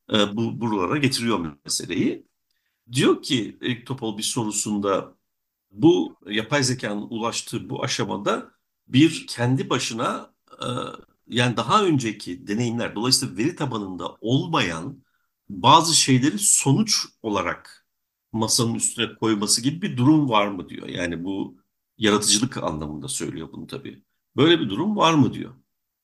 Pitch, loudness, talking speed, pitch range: 115 Hz, -22 LUFS, 125 wpm, 105-125 Hz